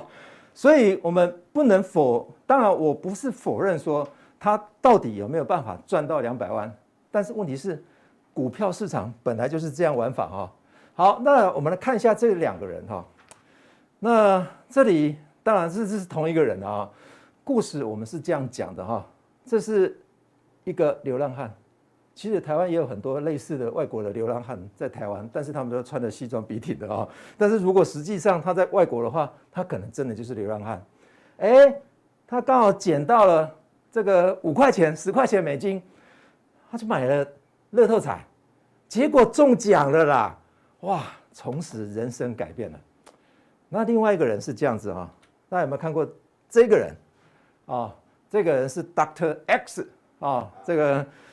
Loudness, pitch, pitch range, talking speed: -23 LUFS, 165 Hz, 140-210 Hz, 260 characters per minute